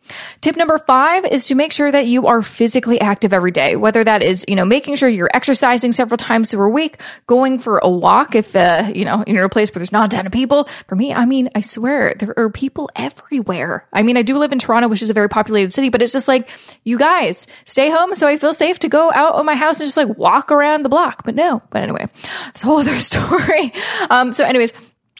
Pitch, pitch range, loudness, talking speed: 250 Hz, 220-290 Hz, -14 LUFS, 255 wpm